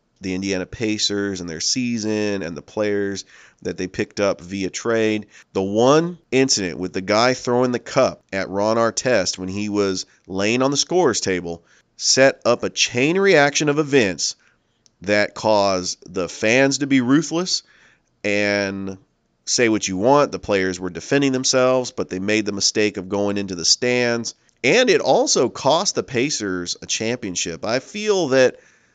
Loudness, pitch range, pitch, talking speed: -19 LUFS, 95-130 Hz, 105 Hz, 165 wpm